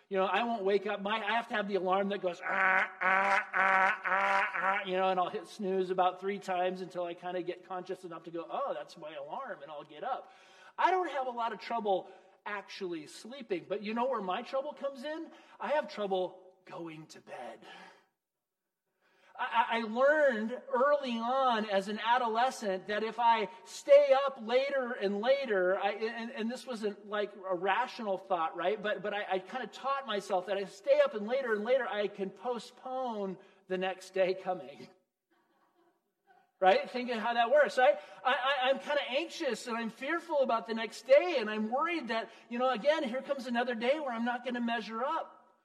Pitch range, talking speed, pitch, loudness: 190-250 Hz, 205 wpm, 205 Hz, -32 LUFS